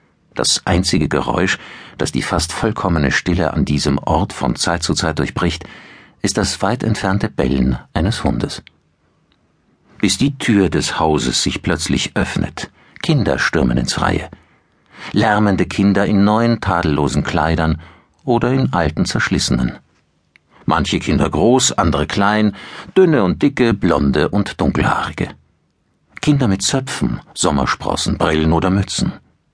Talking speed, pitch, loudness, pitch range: 130 wpm, 95 Hz, -17 LUFS, 80-105 Hz